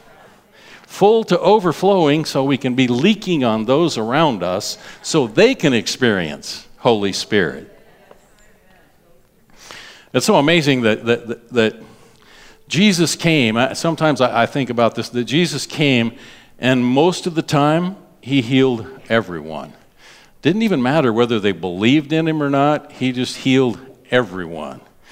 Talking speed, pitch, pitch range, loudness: 135 wpm, 130 Hz, 120-160 Hz, -17 LUFS